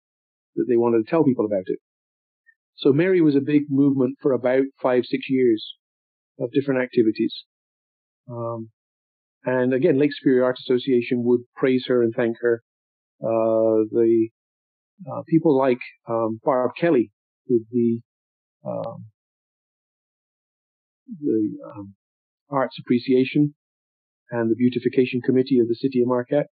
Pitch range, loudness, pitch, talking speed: 115-135 Hz, -22 LUFS, 125 Hz, 135 wpm